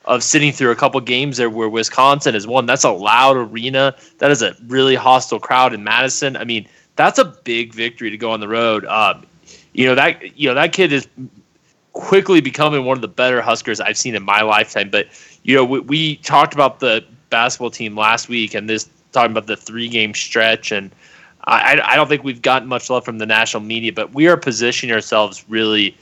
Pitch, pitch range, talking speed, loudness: 125 Hz, 110-135 Hz, 215 wpm, -15 LUFS